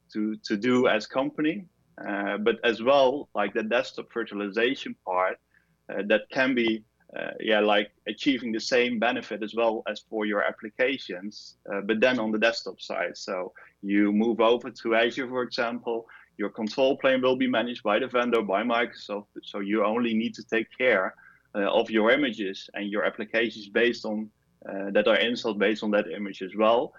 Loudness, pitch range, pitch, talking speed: -26 LUFS, 105-120 Hz, 110 Hz, 185 wpm